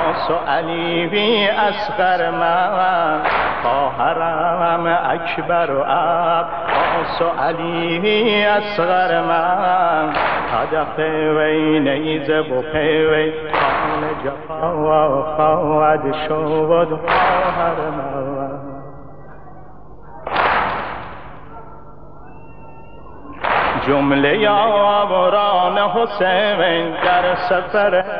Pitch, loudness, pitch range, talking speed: 170 Hz, -17 LUFS, 155-185 Hz, 90 wpm